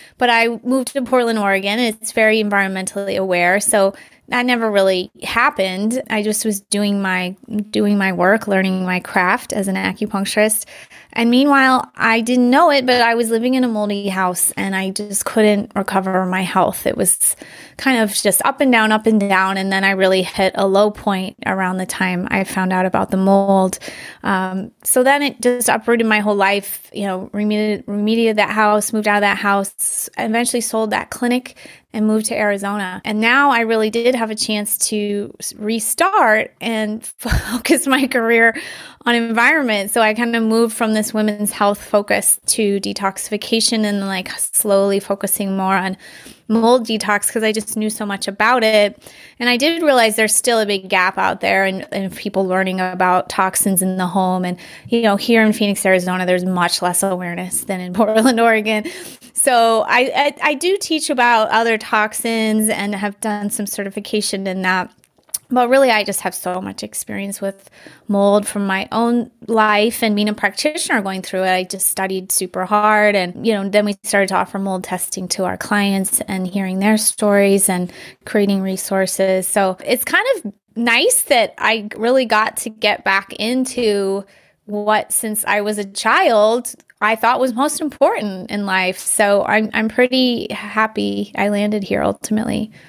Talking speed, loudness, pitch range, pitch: 185 wpm, -16 LUFS, 195-230 Hz, 210 Hz